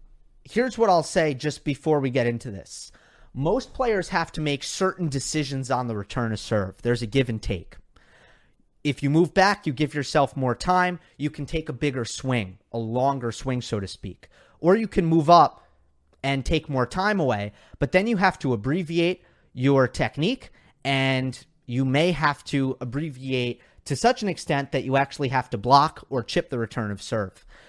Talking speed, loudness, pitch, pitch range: 190 wpm, -24 LUFS, 135 Hz, 120-155 Hz